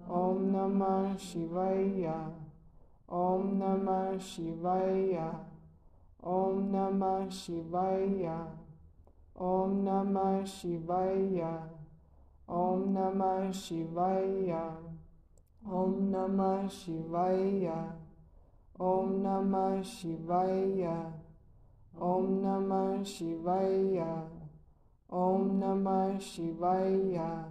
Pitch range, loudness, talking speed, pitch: 165-190 Hz, -33 LUFS, 60 wpm, 185 Hz